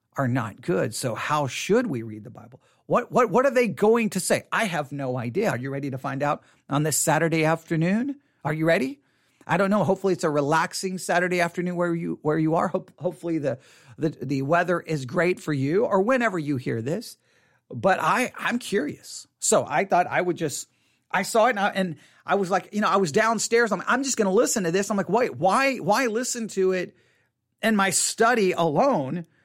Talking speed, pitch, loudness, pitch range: 220 wpm, 175 Hz, -24 LUFS, 155-210 Hz